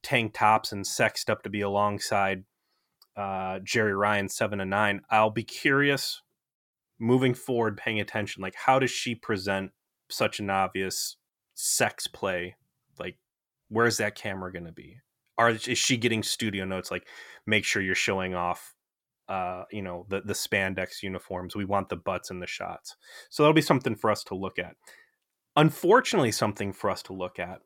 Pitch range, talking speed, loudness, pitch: 95-120 Hz, 170 wpm, -27 LUFS, 105 Hz